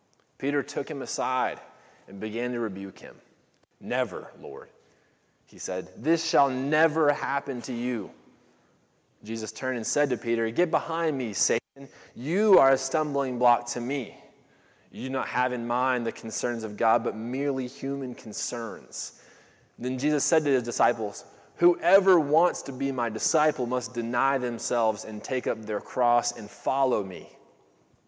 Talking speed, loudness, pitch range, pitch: 155 wpm, -27 LUFS, 120-140 Hz, 125 Hz